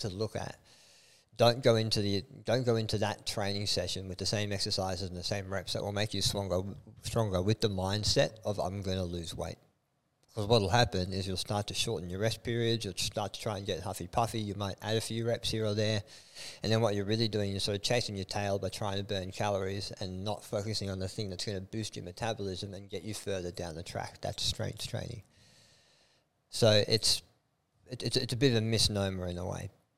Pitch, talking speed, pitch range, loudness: 105 Hz, 235 wpm, 95-115 Hz, -33 LUFS